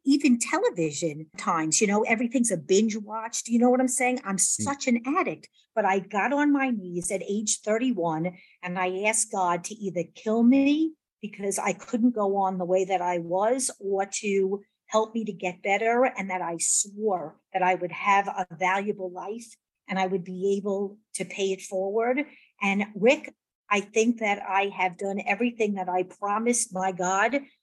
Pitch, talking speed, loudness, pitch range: 200 Hz, 190 wpm, -26 LUFS, 185-230 Hz